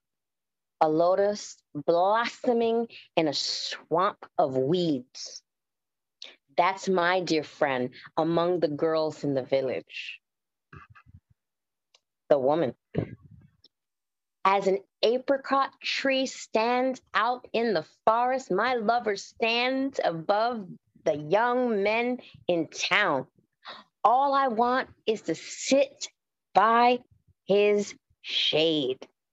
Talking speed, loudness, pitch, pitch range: 95 wpm, -26 LUFS, 210 Hz, 170-245 Hz